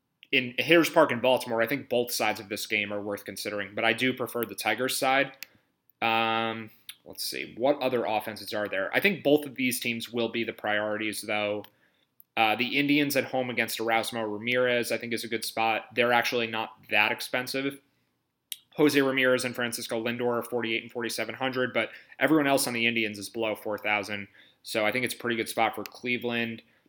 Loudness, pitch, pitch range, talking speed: -27 LUFS, 120 Hz, 110-125 Hz, 200 wpm